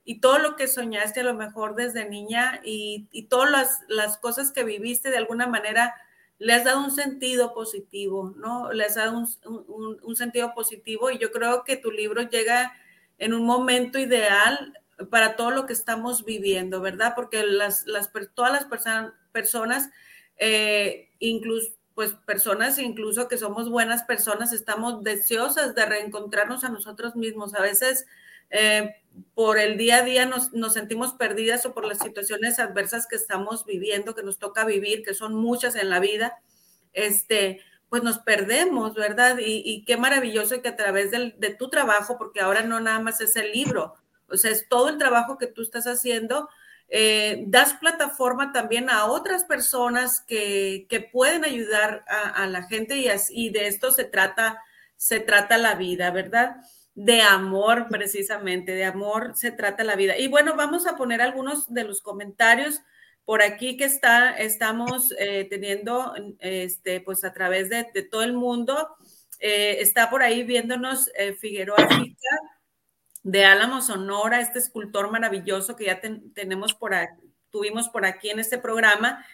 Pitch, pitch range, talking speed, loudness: 225 Hz, 210-245 Hz, 175 wpm, -23 LUFS